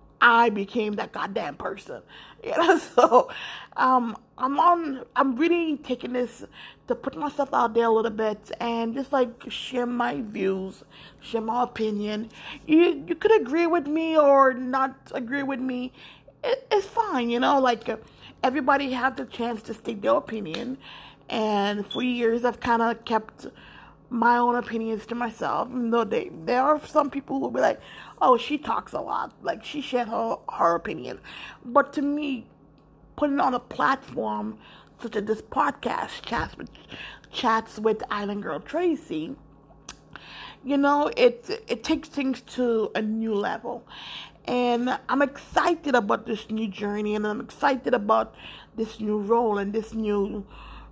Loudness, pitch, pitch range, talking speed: -25 LUFS, 245 Hz, 225-280 Hz, 160 wpm